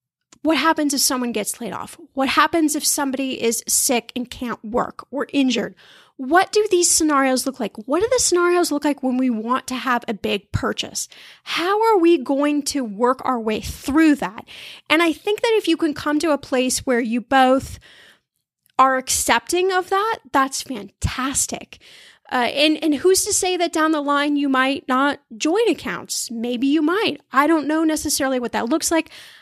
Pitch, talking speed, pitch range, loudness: 285 Hz, 190 wpm, 255-325 Hz, -19 LUFS